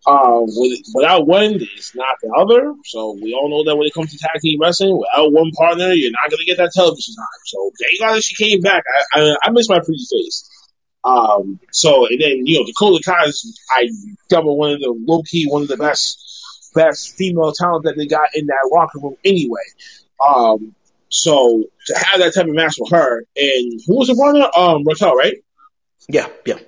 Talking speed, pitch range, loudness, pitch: 210 wpm, 150-225 Hz, -14 LUFS, 170 Hz